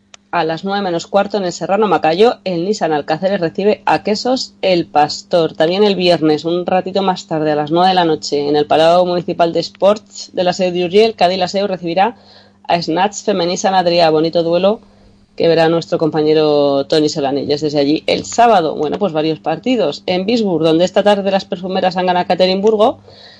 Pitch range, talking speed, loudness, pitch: 160-195 Hz, 185 wpm, -14 LUFS, 175 Hz